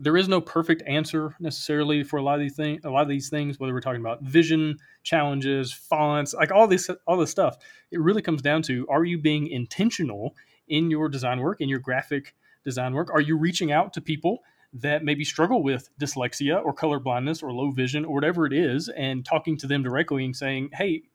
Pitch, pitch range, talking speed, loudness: 150 Hz, 135-160 Hz, 220 wpm, -25 LUFS